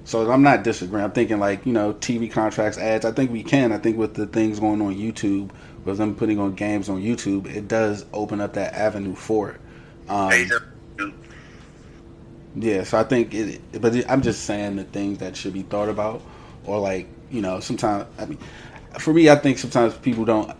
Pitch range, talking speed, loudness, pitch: 100-115 Hz, 205 wpm, -22 LUFS, 105 Hz